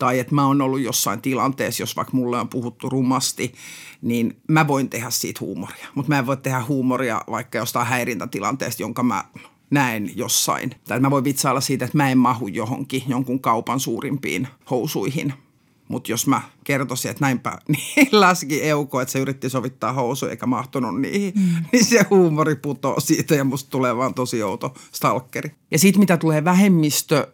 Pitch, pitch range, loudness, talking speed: 135 Hz, 130-150 Hz, -21 LUFS, 180 wpm